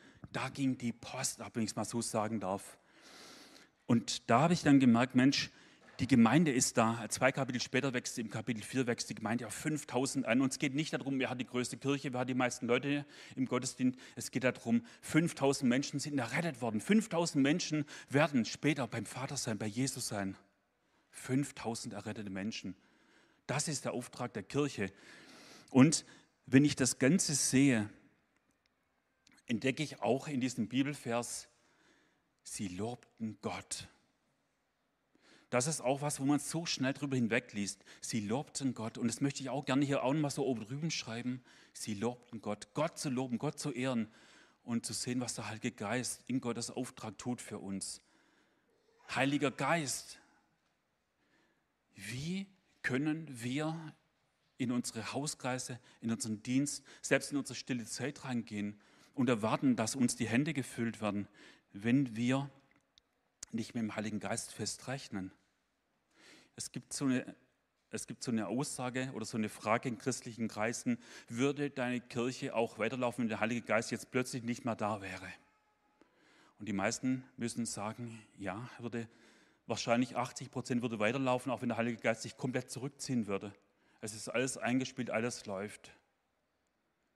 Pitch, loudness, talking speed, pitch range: 125 Hz, -35 LUFS, 160 wpm, 115-135 Hz